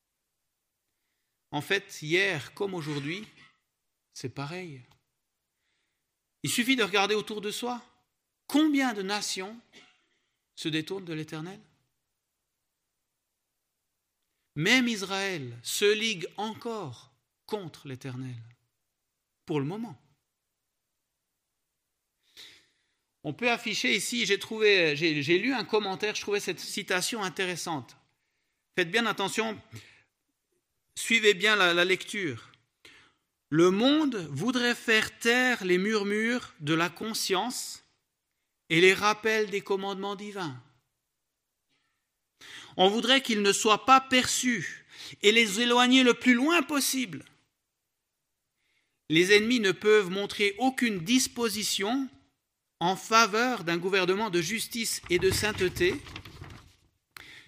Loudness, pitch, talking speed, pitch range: -26 LUFS, 200 Hz, 105 wpm, 165-230 Hz